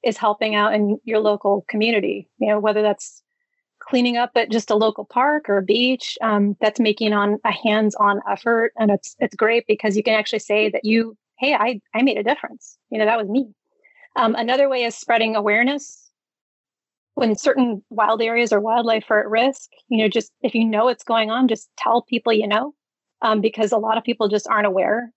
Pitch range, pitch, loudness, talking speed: 215-240 Hz, 225 Hz, -19 LUFS, 210 wpm